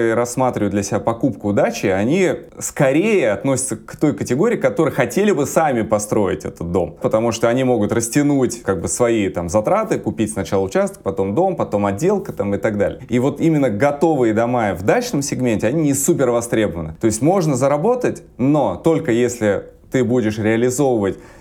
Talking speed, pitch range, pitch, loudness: 170 wpm, 110-145 Hz, 120 Hz, -18 LUFS